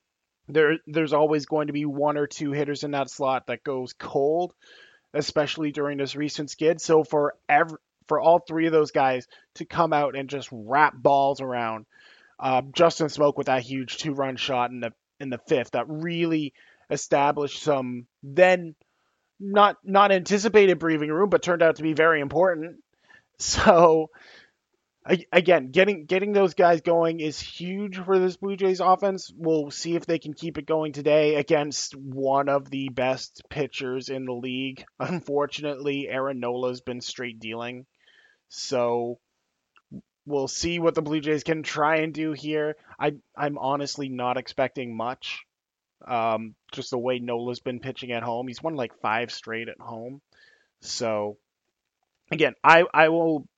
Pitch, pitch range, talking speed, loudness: 145 Hz, 130-165 Hz, 165 wpm, -24 LUFS